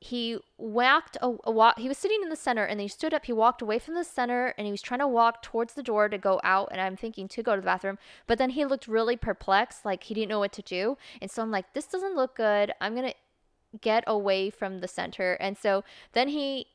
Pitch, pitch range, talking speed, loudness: 225 Hz, 200-255 Hz, 260 wpm, -28 LUFS